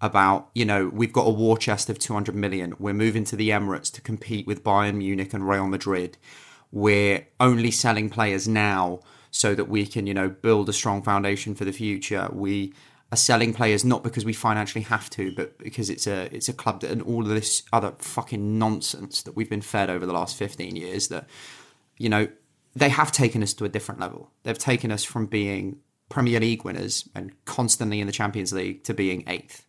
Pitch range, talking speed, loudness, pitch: 100-115 Hz, 210 wpm, -24 LUFS, 105 Hz